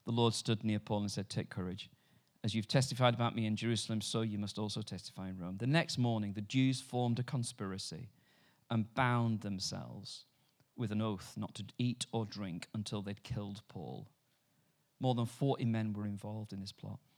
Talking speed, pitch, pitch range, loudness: 190 wpm, 110 Hz, 105-125 Hz, -37 LUFS